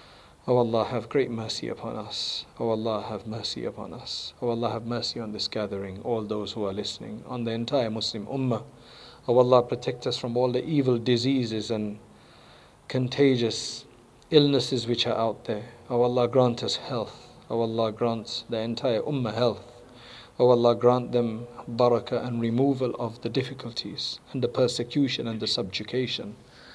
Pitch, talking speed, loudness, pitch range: 120 Hz, 180 wpm, -27 LUFS, 110-125 Hz